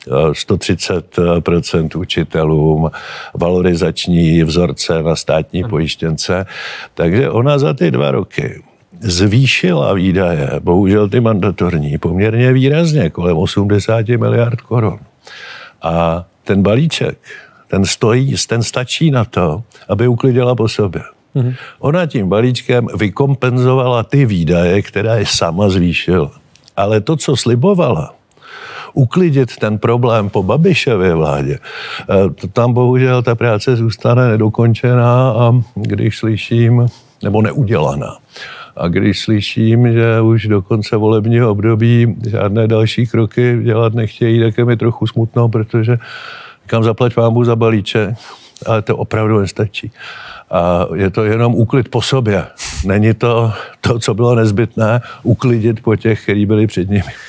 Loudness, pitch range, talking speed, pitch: -13 LUFS, 100-120 Hz, 125 wpm, 115 Hz